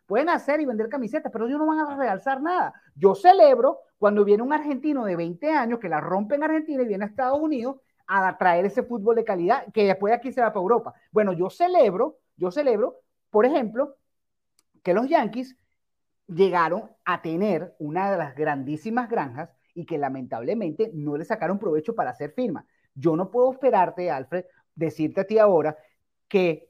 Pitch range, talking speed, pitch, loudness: 175-270 Hz, 185 wpm, 220 Hz, -24 LUFS